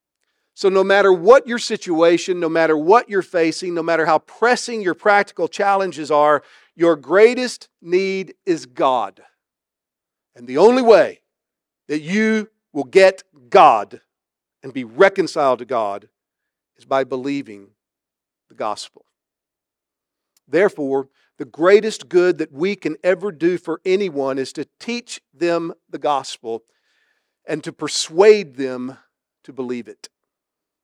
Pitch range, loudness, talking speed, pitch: 150-200 Hz, -17 LUFS, 130 wpm, 175 Hz